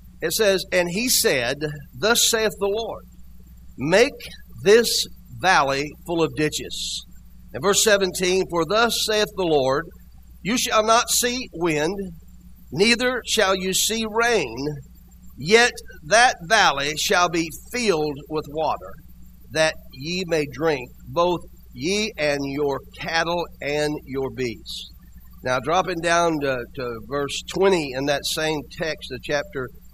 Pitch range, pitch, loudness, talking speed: 135-195 Hz, 160 Hz, -21 LUFS, 130 wpm